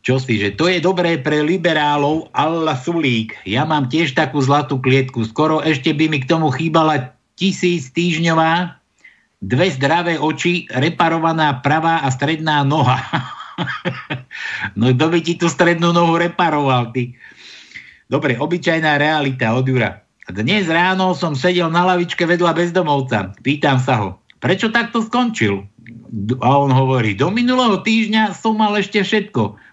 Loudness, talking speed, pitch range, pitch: -16 LUFS, 145 wpm, 130-175 Hz, 155 Hz